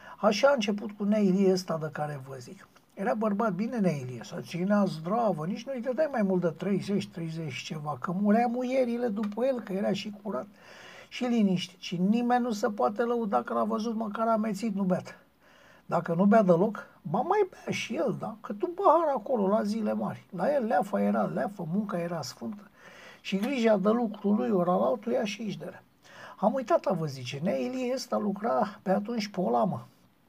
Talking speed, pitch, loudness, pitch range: 190 wpm, 210 Hz, -29 LUFS, 180-235 Hz